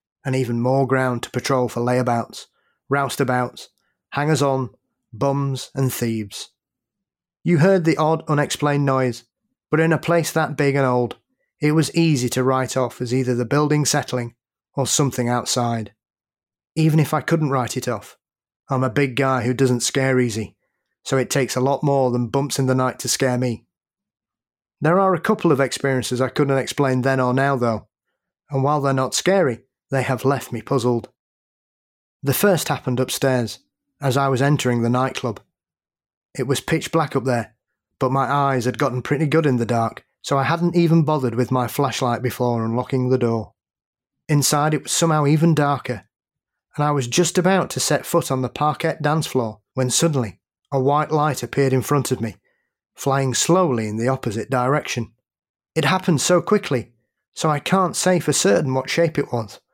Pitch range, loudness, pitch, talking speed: 125-150 Hz, -20 LUFS, 135 Hz, 180 wpm